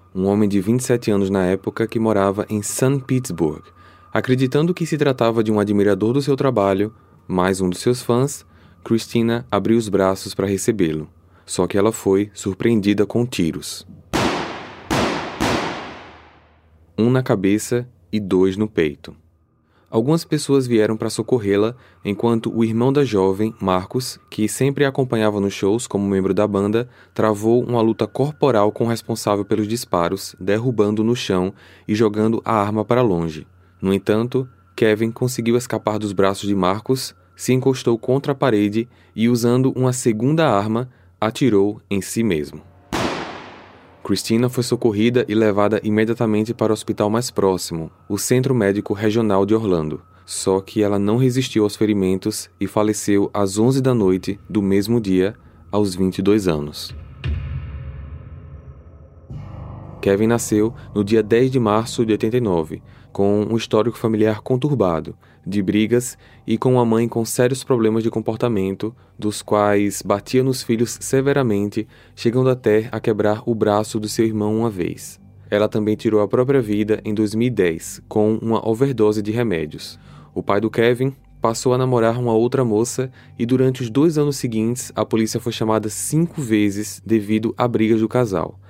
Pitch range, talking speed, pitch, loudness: 100-120 Hz, 155 wpm, 110 Hz, -19 LUFS